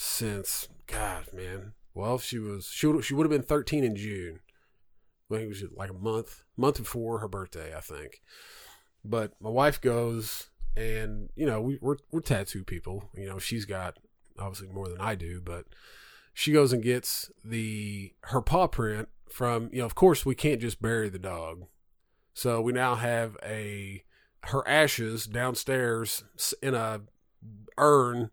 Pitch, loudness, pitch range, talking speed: 110 Hz, -29 LUFS, 100-125 Hz, 175 wpm